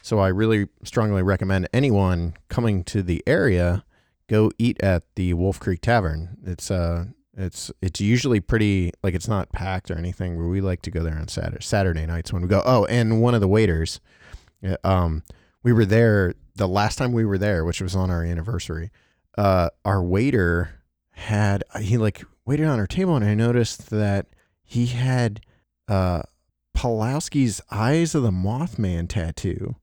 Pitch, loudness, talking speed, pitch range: 100 Hz, -23 LUFS, 175 wpm, 90-115 Hz